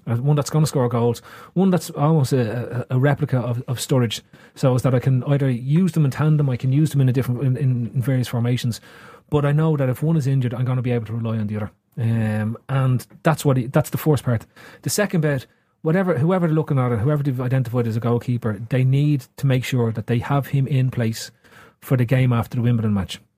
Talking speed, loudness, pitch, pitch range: 250 wpm, -21 LUFS, 130 Hz, 120-145 Hz